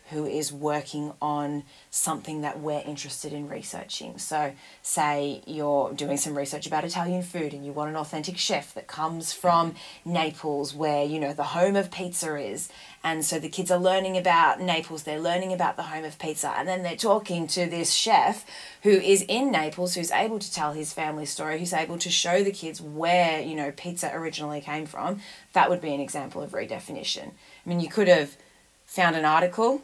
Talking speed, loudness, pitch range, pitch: 195 wpm, -26 LUFS, 150-180 Hz, 160 Hz